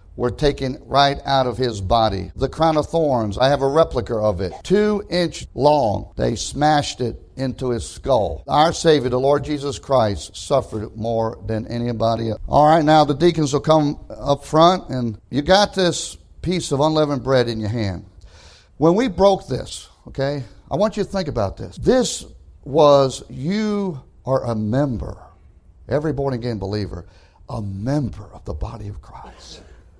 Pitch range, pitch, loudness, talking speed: 105-150 Hz, 130 Hz, -19 LUFS, 170 wpm